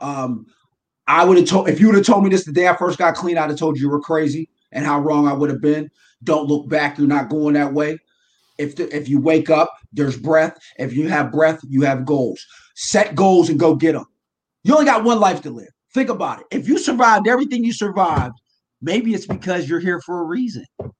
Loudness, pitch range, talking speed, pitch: -17 LUFS, 145-190 Hz, 245 wpm, 160 Hz